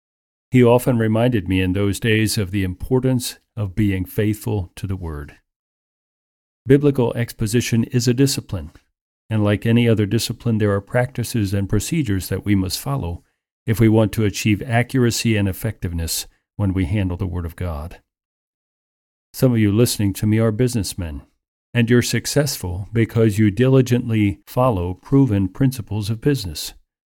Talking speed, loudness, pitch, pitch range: 155 wpm, -19 LUFS, 110 Hz, 95-120 Hz